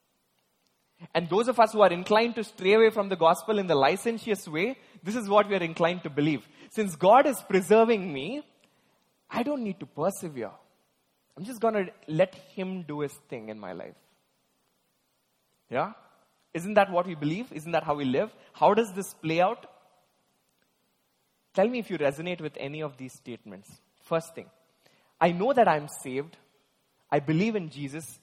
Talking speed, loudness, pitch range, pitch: 180 wpm, -27 LUFS, 160-215 Hz, 185 Hz